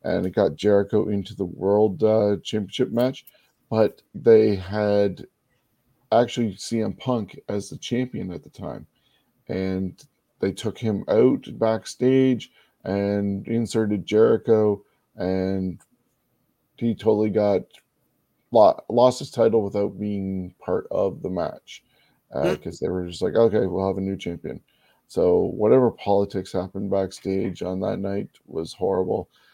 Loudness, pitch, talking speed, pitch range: -23 LUFS, 100 Hz, 135 wpm, 95-110 Hz